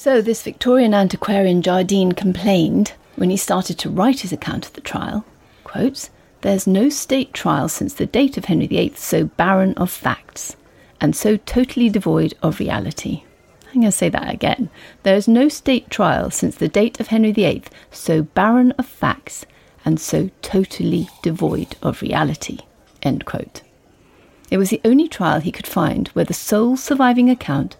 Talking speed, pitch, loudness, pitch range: 170 wpm, 210 Hz, -18 LUFS, 190-250 Hz